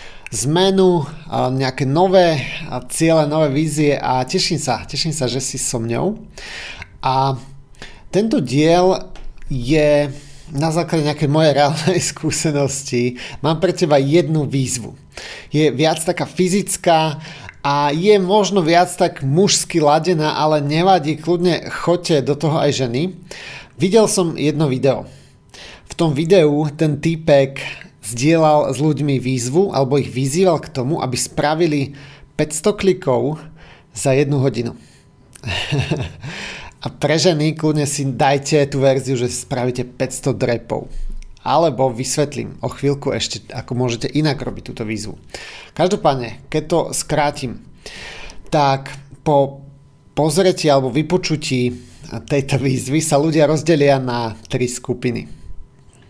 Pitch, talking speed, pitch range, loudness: 145 Hz, 120 wpm, 135-160 Hz, -17 LUFS